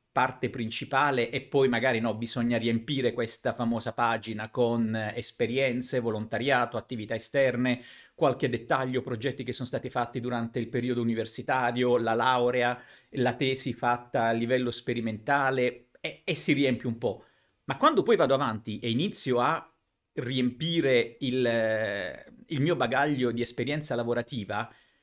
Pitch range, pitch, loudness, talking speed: 115-130 Hz, 125 Hz, -28 LUFS, 135 wpm